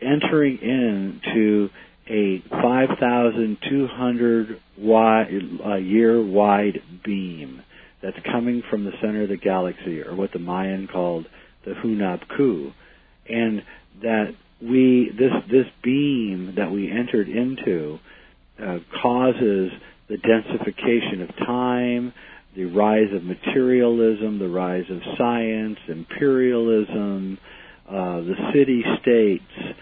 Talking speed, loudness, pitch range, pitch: 100 wpm, -21 LUFS, 95-120 Hz, 110 Hz